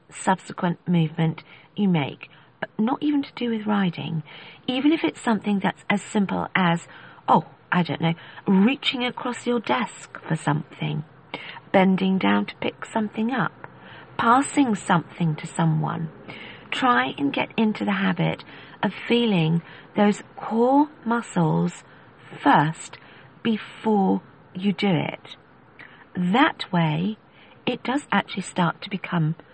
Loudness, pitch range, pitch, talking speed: -24 LUFS, 160-225 Hz, 180 Hz, 130 wpm